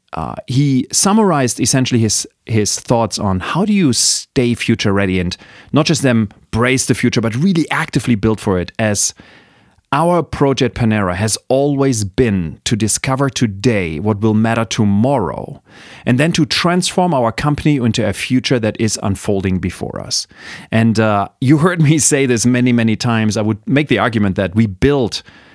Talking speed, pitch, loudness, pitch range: 170 wpm, 120 Hz, -15 LUFS, 105-135 Hz